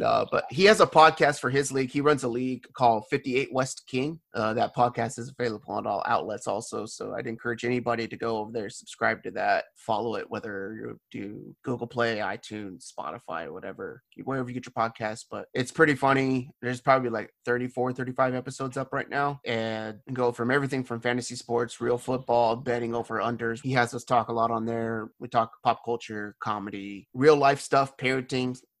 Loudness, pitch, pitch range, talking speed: -27 LUFS, 120 Hz, 115-130 Hz, 195 wpm